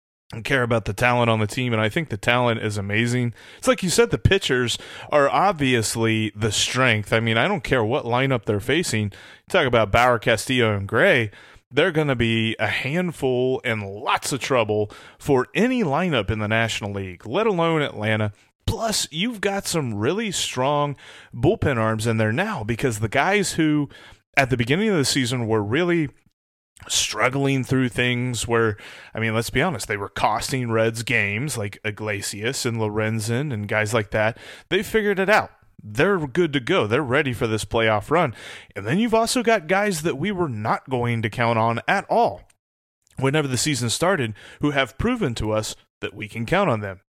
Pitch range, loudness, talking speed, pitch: 110-150 Hz, -22 LUFS, 190 wpm, 120 Hz